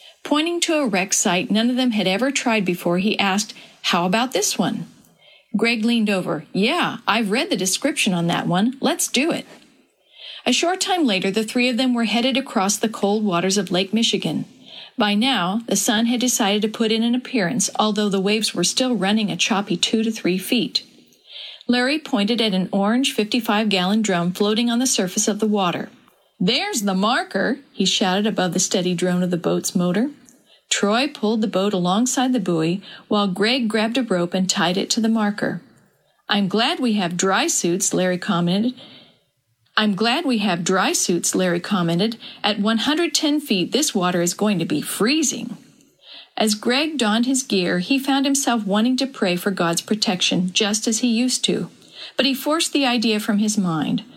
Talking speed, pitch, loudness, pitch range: 190 wpm, 220 Hz, -20 LUFS, 190-250 Hz